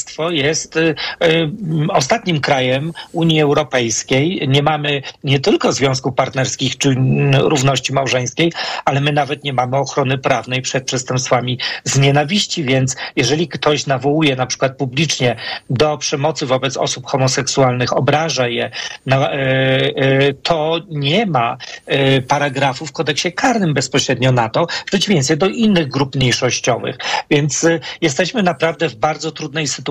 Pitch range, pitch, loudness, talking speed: 135-160 Hz, 145 Hz, -16 LUFS, 140 wpm